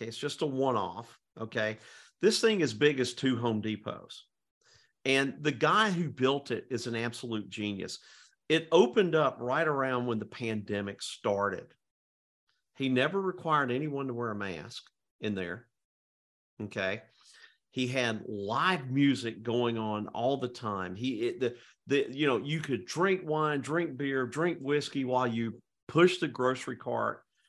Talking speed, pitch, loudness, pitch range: 160 wpm, 125 Hz, -31 LUFS, 110-150 Hz